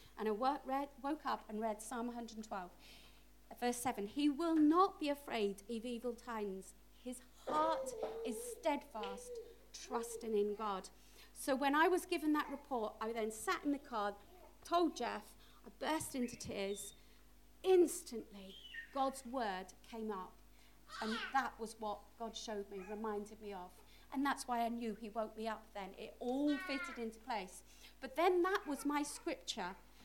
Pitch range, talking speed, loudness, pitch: 215-290 Hz, 160 wpm, -40 LUFS, 240 Hz